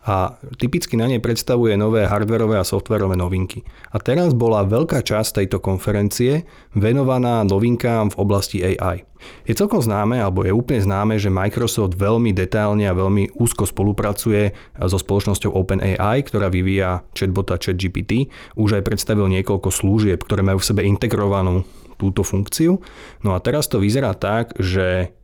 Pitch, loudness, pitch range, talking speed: 105 Hz, -19 LUFS, 95-115 Hz, 150 wpm